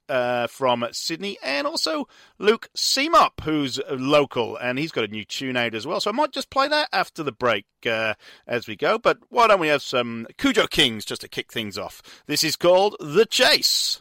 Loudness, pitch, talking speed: -22 LUFS, 155 Hz, 210 wpm